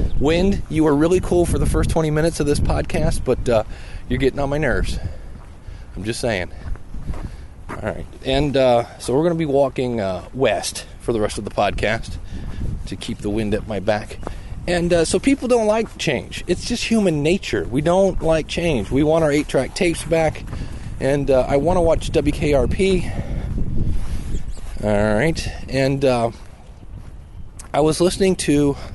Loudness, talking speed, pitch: -20 LUFS, 175 wpm, 125 Hz